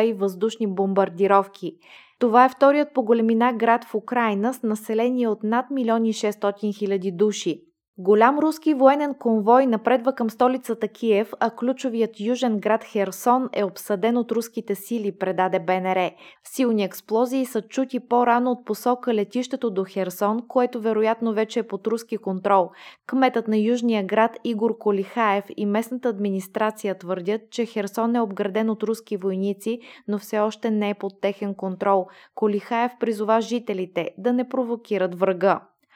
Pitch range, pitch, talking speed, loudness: 205-240 Hz, 225 Hz, 145 wpm, -23 LUFS